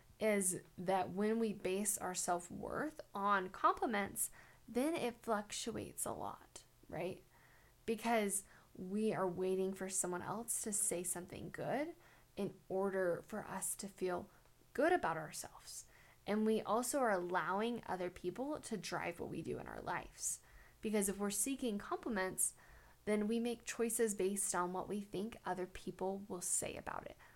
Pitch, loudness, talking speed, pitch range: 200 Hz, -40 LUFS, 155 wpm, 185-225 Hz